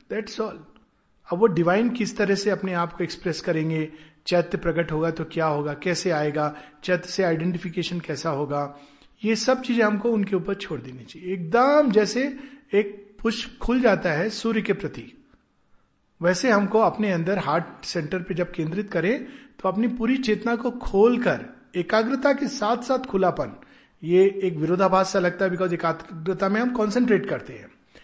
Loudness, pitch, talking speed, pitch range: -24 LUFS, 190 Hz, 170 wpm, 170-225 Hz